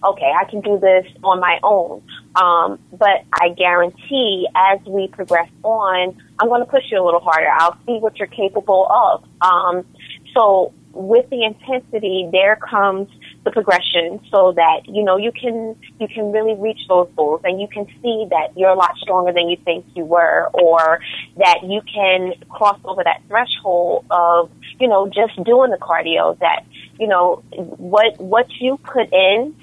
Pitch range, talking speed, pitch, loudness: 180-220 Hz, 180 wpm, 195 Hz, -16 LUFS